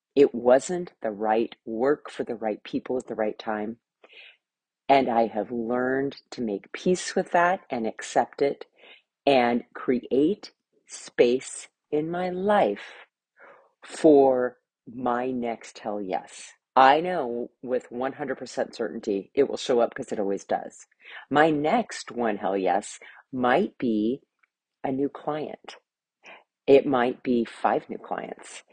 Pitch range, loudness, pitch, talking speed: 115-145 Hz, -25 LUFS, 125 Hz, 135 wpm